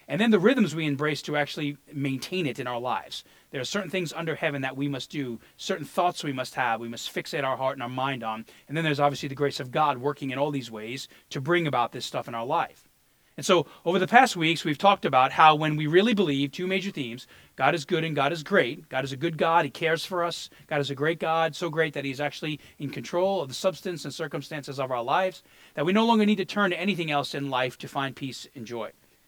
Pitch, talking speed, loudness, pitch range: 150 Hz, 260 wpm, -26 LUFS, 135-175 Hz